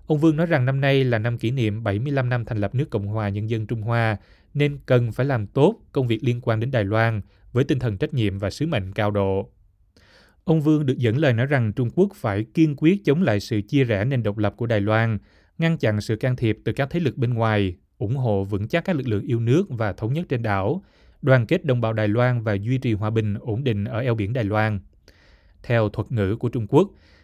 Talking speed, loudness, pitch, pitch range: 255 wpm, -23 LUFS, 115 Hz, 105-135 Hz